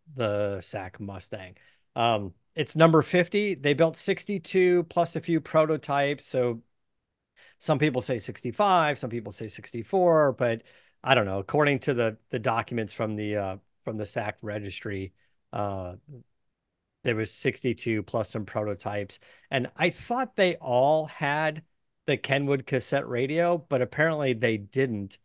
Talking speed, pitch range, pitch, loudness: 145 wpm, 105-155 Hz, 125 Hz, -27 LUFS